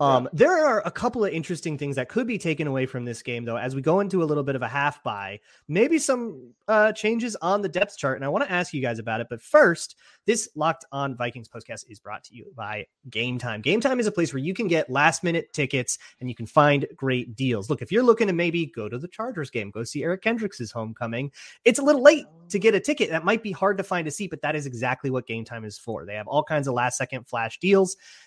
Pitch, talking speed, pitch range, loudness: 150 Hz, 270 wpm, 125-200 Hz, -24 LUFS